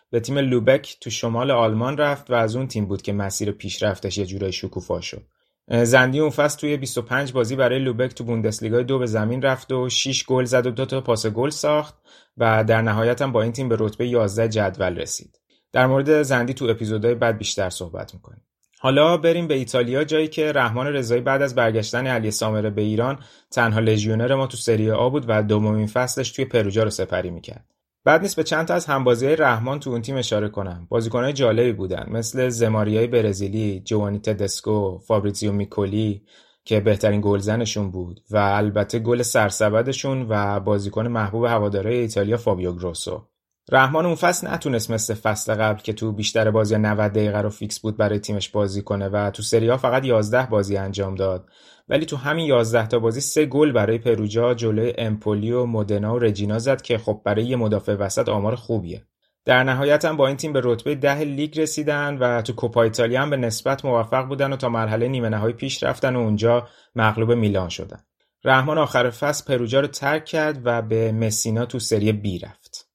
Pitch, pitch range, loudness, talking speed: 115 Hz, 105-130 Hz, -21 LUFS, 190 wpm